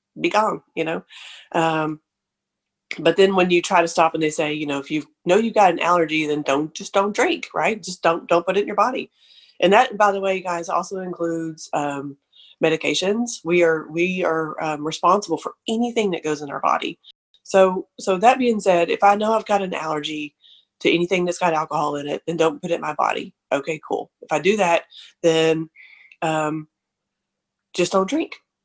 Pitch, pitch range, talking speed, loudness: 170 Hz, 155-190 Hz, 205 wpm, -21 LUFS